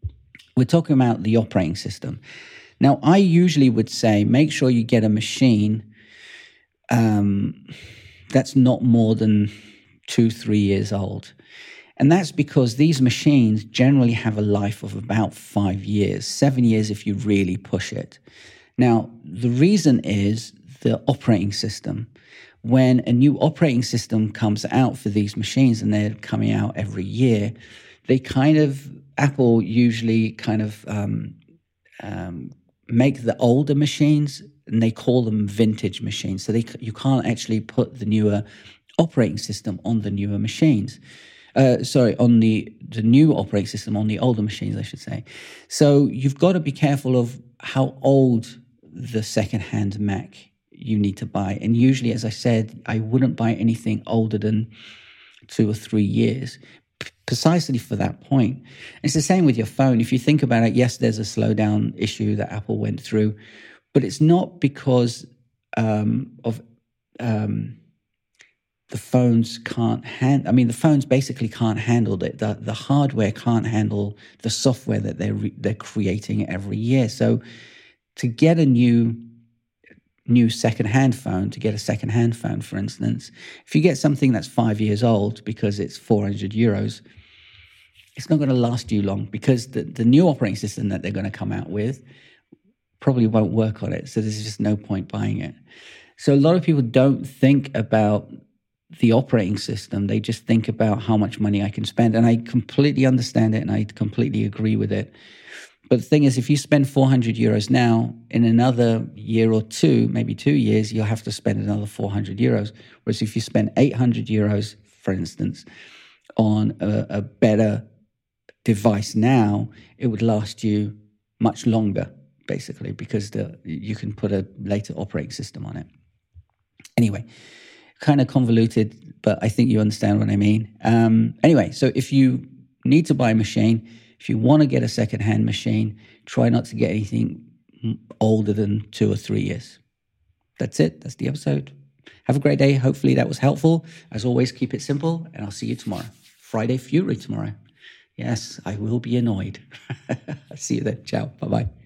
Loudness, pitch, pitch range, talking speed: -21 LUFS, 115 Hz, 105-125 Hz, 170 wpm